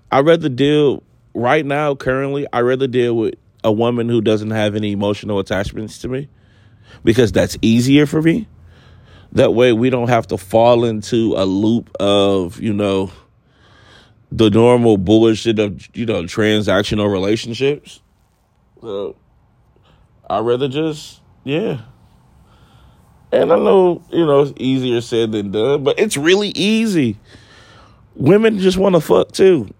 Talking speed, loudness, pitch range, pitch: 140 wpm, -16 LUFS, 105-135 Hz, 115 Hz